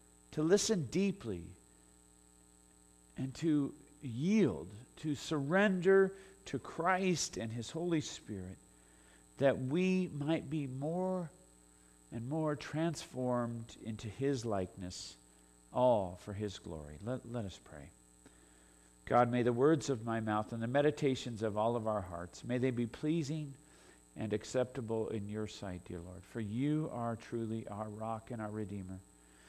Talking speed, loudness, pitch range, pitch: 140 wpm, -36 LUFS, 90-145 Hz, 115 Hz